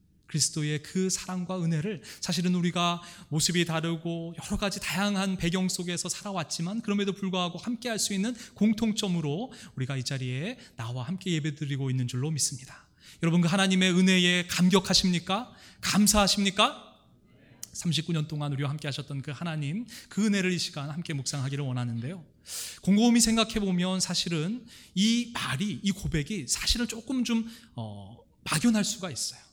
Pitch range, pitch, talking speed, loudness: 150-200 Hz, 180 Hz, 355 characters per minute, -28 LUFS